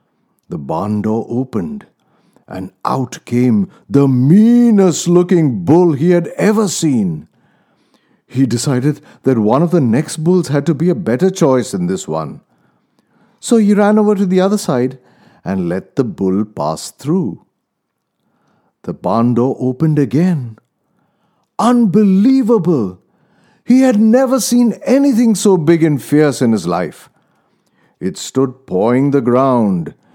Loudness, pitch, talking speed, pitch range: -13 LUFS, 170 Hz, 135 wpm, 130-210 Hz